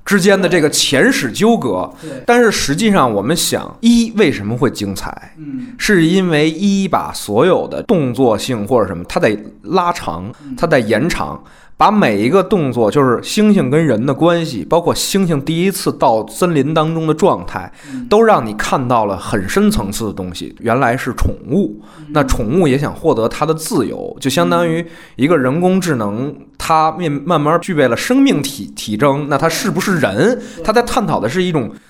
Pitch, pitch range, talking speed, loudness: 175 Hz, 150-210 Hz, 265 characters per minute, -14 LUFS